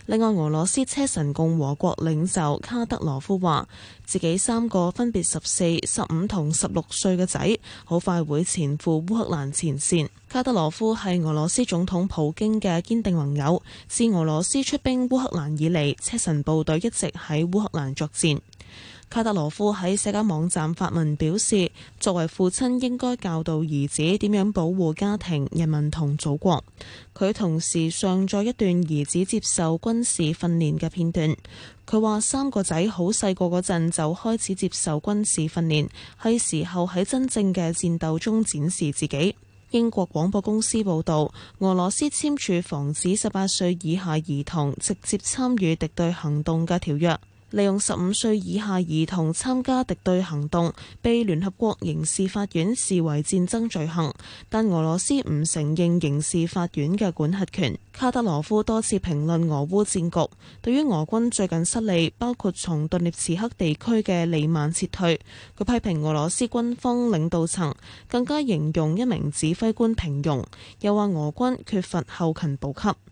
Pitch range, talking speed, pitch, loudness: 155-210 Hz, 255 characters per minute, 175 Hz, -24 LUFS